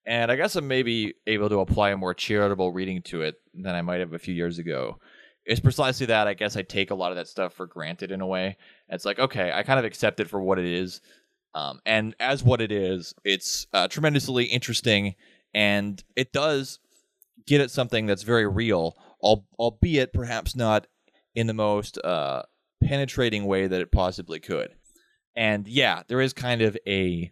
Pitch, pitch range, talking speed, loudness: 105 Hz, 95-125 Hz, 200 wpm, -25 LUFS